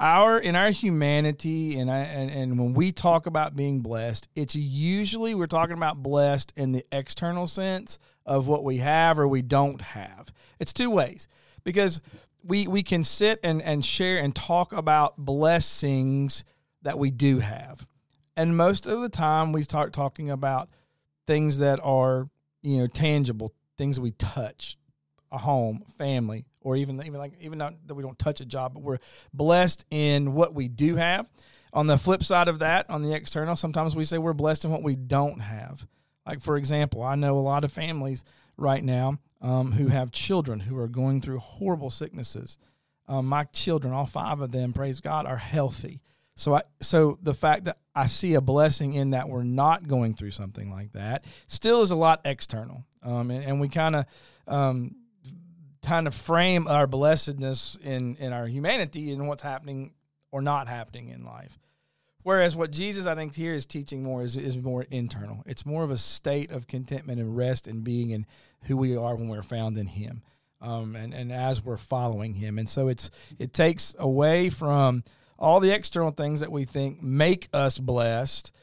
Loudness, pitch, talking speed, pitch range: -26 LUFS, 140 Hz, 190 wpm, 130-155 Hz